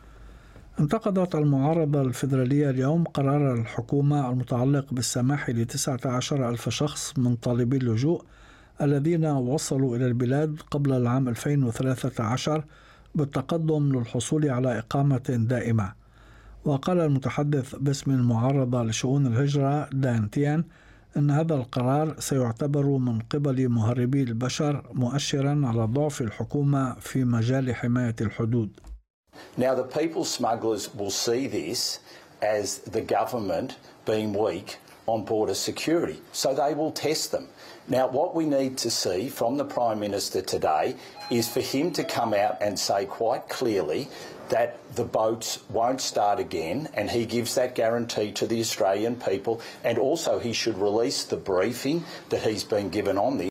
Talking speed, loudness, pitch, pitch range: 135 wpm, -26 LUFS, 130 Hz, 115-145 Hz